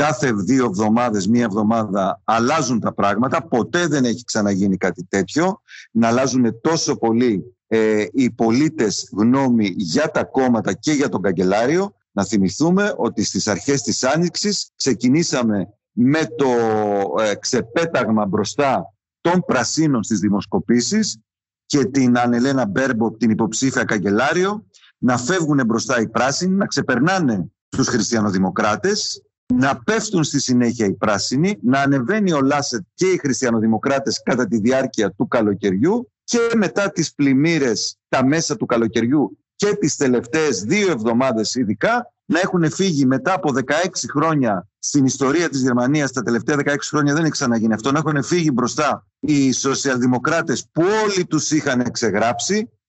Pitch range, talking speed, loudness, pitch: 110-160 Hz, 140 wpm, -19 LUFS, 130 Hz